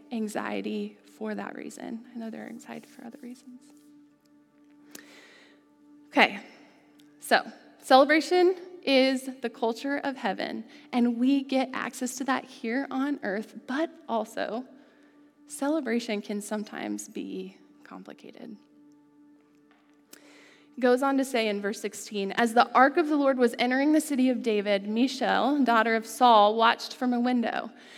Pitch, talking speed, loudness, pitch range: 250 Hz, 135 wpm, -26 LUFS, 220-290 Hz